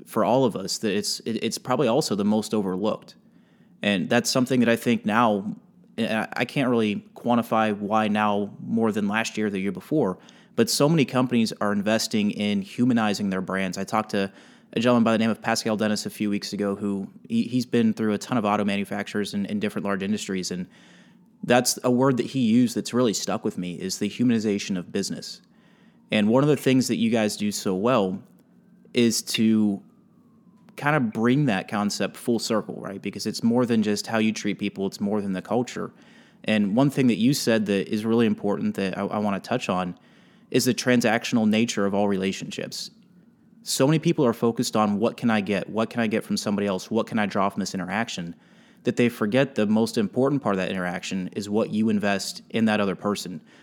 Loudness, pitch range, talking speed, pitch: -24 LUFS, 100-125 Hz, 215 wpm, 110 Hz